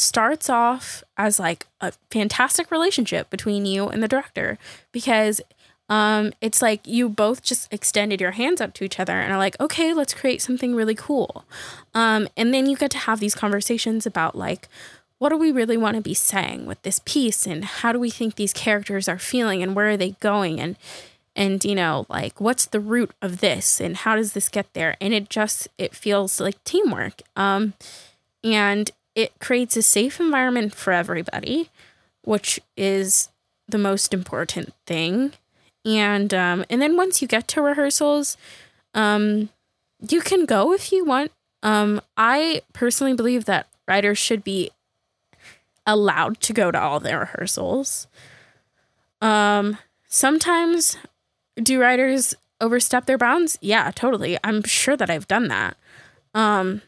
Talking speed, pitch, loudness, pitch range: 165 wpm, 220 Hz, -20 LUFS, 200-255 Hz